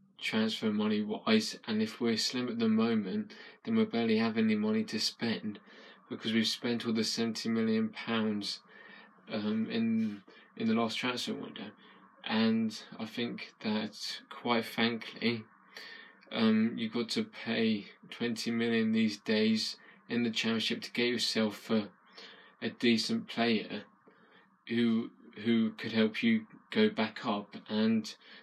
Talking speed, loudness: 140 wpm, -32 LUFS